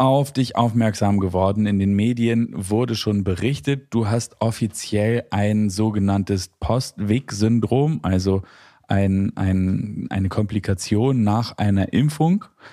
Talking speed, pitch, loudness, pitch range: 115 wpm, 105 Hz, -21 LUFS, 100-115 Hz